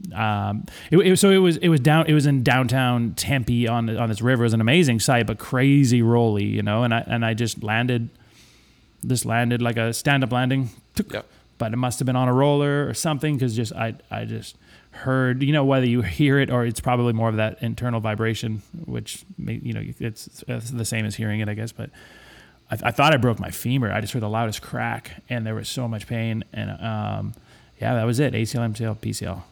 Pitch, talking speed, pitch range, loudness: 120 Hz, 230 wpm, 110-130 Hz, -22 LUFS